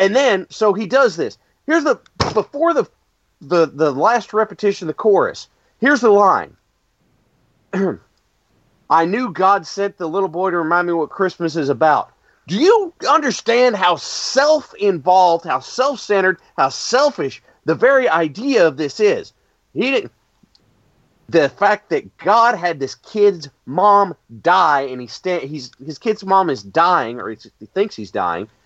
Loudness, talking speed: -17 LUFS, 160 wpm